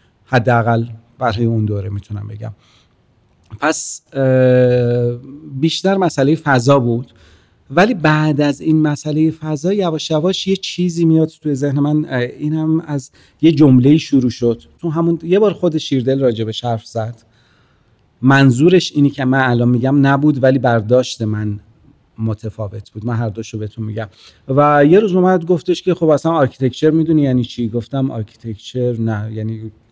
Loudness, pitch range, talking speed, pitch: -15 LUFS, 115-155 Hz, 150 wpm, 130 Hz